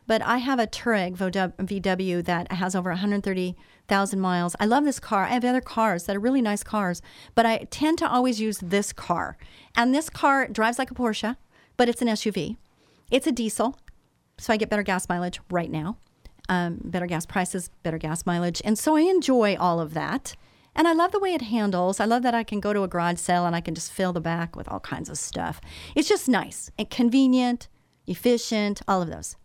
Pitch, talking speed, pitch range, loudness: 210 Hz, 215 wpm, 180-245 Hz, -25 LUFS